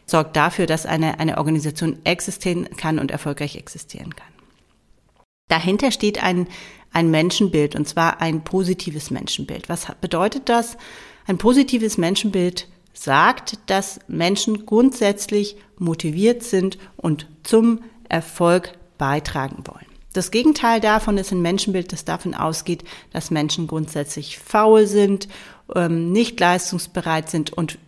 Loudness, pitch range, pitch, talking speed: -20 LUFS, 160-205 Hz, 180 Hz, 125 wpm